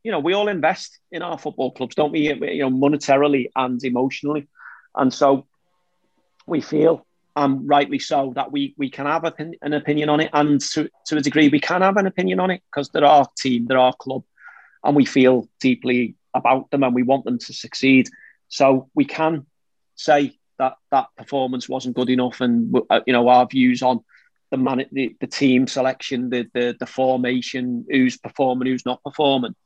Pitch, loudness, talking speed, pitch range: 135 Hz, -20 LUFS, 190 wpm, 130-150 Hz